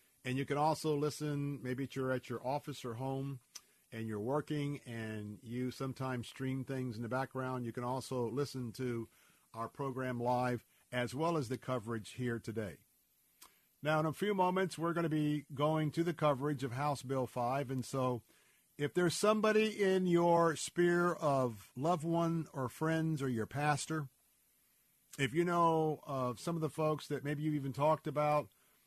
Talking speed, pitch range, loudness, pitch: 175 wpm, 125-155 Hz, -36 LUFS, 140 Hz